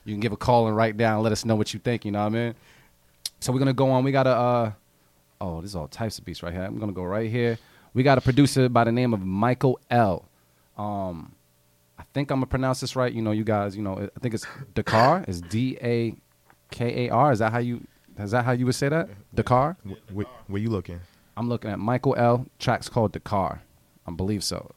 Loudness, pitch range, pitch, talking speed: -25 LUFS, 100-125 Hz, 115 Hz, 250 wpm